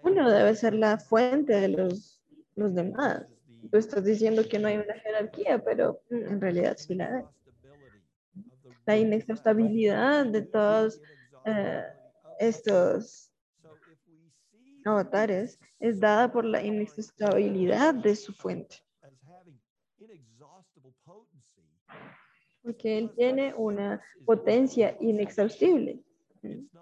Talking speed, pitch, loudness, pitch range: 100 wpm, 210 Hz, -27 LUFS, 180-225 Hz